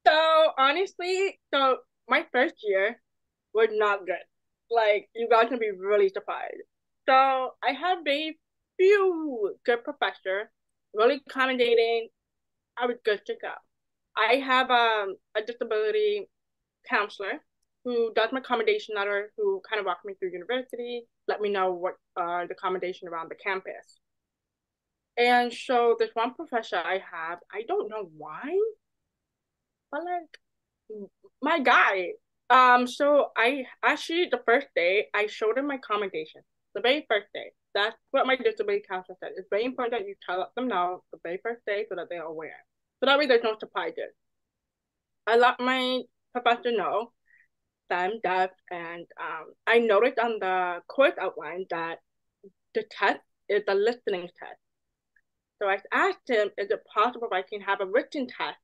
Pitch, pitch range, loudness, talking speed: 235 Hz, 200-280 Hz, -26 LUFS, 160 wpm